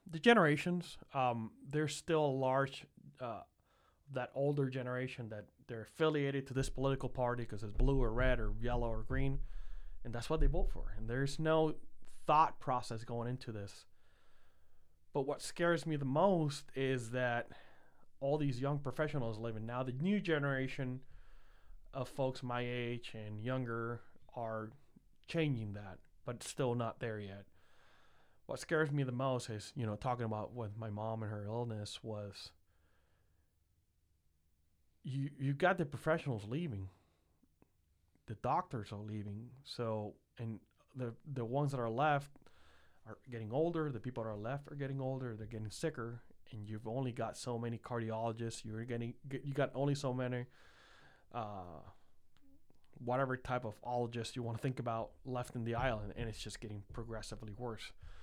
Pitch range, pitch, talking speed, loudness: 105-135 Hz, 120 Hz, 160 wpm, -39 LUFS